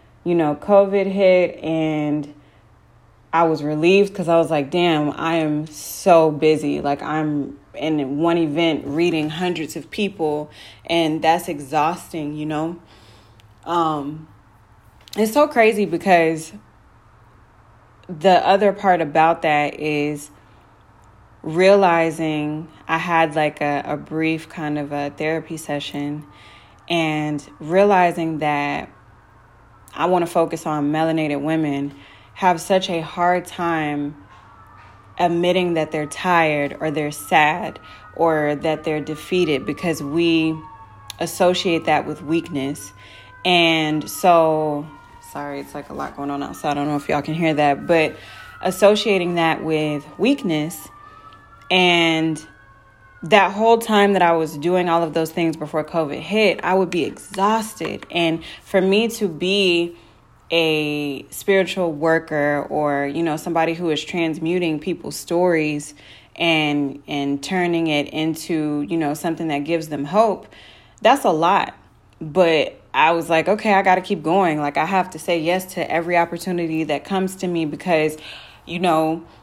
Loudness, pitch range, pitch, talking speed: -19 LUFS, 145-175 Hz, 160 Hz, 140 wpm